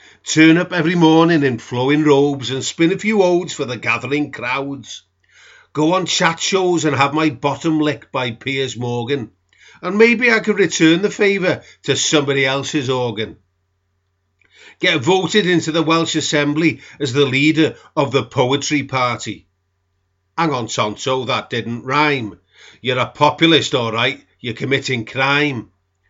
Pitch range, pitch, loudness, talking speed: 120-160 Hz, 140 Hz, -16 LUFS, 150 wpm